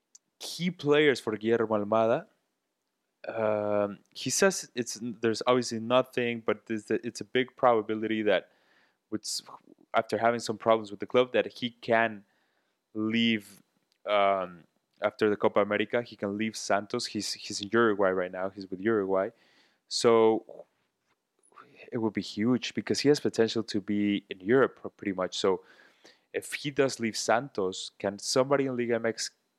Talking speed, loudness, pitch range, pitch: 150 wpm, -29 LUFS, 105-125 Hz, 115 Hz